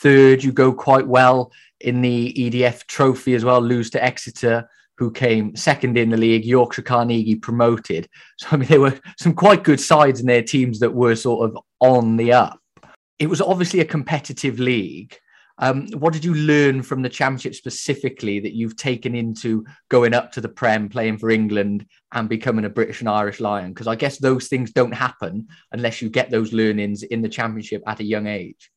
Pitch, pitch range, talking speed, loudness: 120 Hz, 115-135 Hz, 200 wpm, -19 LUFS